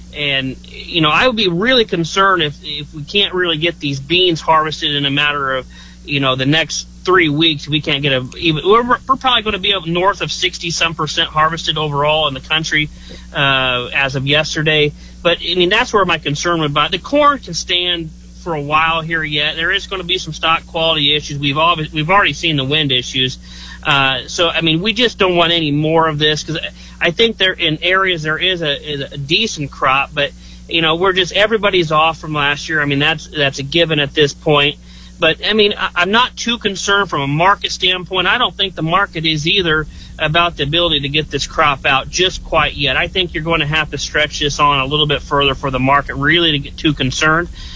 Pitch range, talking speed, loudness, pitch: 145-175 Hz, 235 wpm, -14 LUFS, 155 Hz